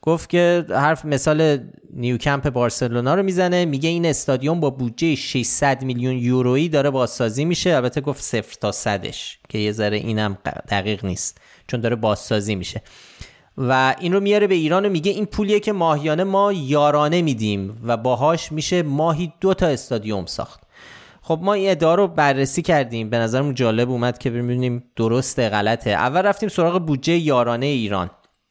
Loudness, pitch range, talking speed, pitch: -20 LUFS, 120-165 Hz, 160 wpm, 135 Hz